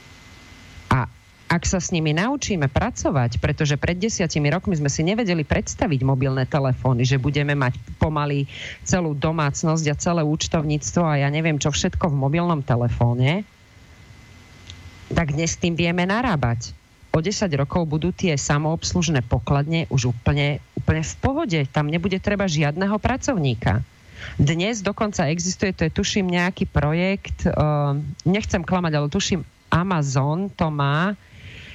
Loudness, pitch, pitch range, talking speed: -22 LUFS, 150 Hz, 130-175 Hz, 135 wpm